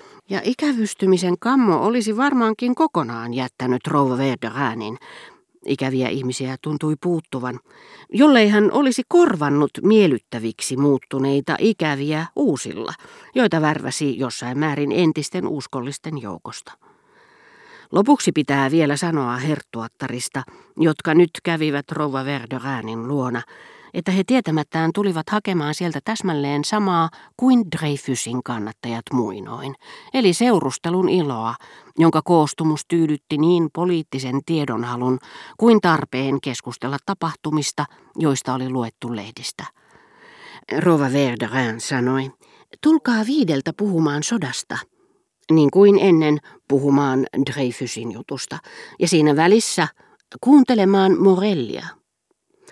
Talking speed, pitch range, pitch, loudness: 100 wpm, 135-195 Hz, 155 Hz, -20 LUFS